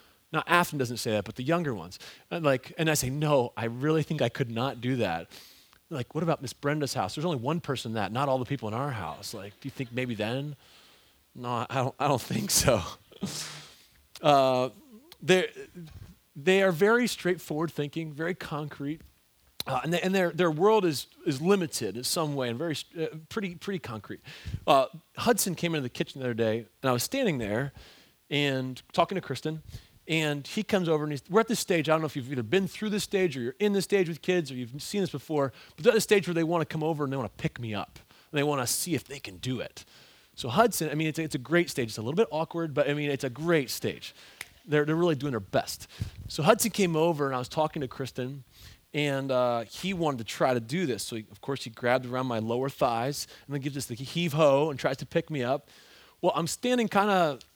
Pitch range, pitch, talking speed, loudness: 125-170 Hz, 145 Hz, 245 wpm, -29 LUFS